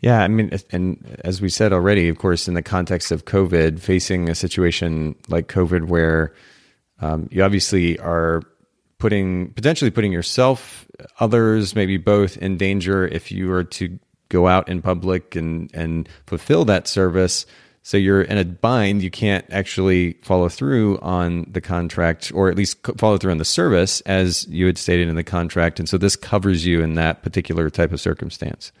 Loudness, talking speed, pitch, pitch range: -19 LUFS, 180 wpm, 90 Hz, 85-100 Hz